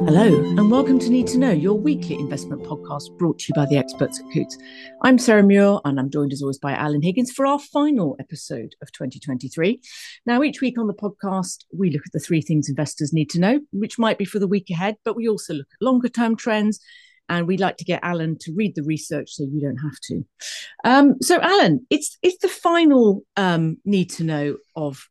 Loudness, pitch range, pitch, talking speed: -20 LUFS, 150-240 Hz, 185 Hz, 220 wpm